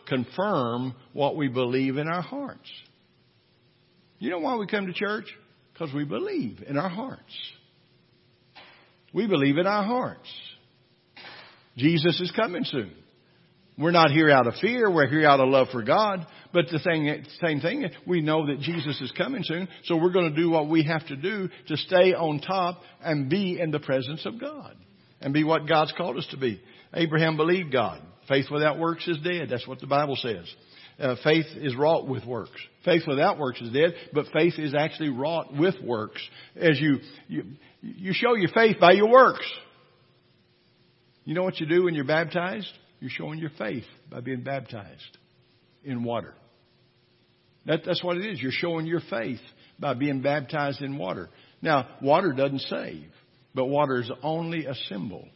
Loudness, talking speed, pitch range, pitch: -25 LUFS, 180 wpm, 140-180 Hz, 155 Hz